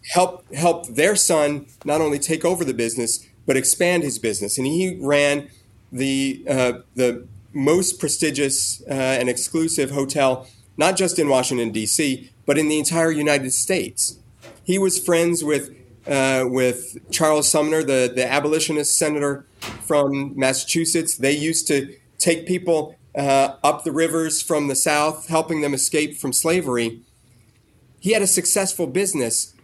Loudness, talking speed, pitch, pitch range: -20 LUFS, 150 wpm, 145 Hz, 130-160 Hz